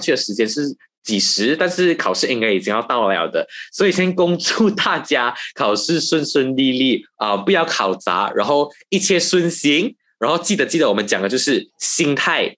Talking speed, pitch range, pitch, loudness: 275 characters per minute, 130-180 Hz, 160 Hz, -17 LUFS